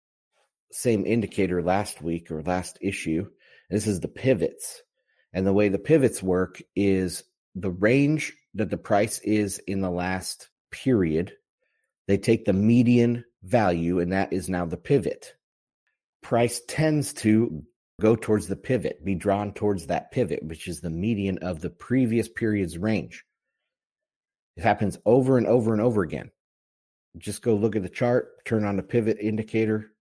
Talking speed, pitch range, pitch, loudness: 160 wpm, 90-115 Hz, 100 Hz, -25 LUFS